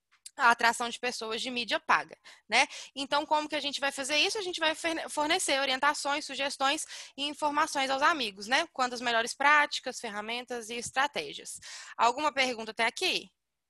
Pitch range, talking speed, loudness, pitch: 245-300 Hz, 165 wpm, -29 LUFS, 275 Hz